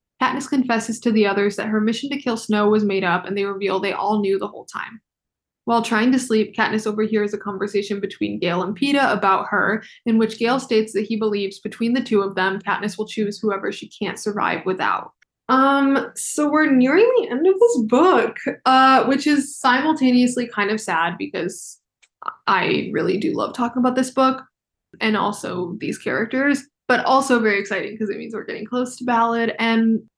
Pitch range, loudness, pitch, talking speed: 205-260 Hz, -20 LUFS, 225 Hz, 195 wpm